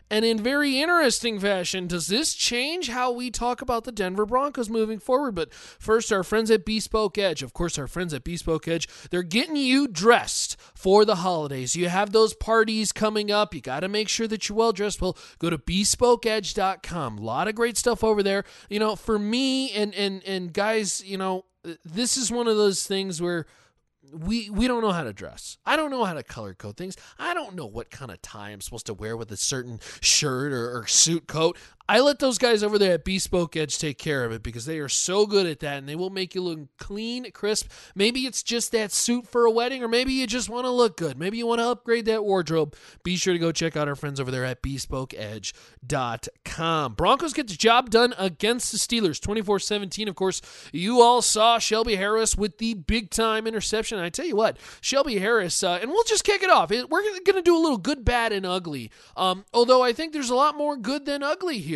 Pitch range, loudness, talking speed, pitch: 170-235 Hz, -24 LUFS, 225 wpm, 210 Hz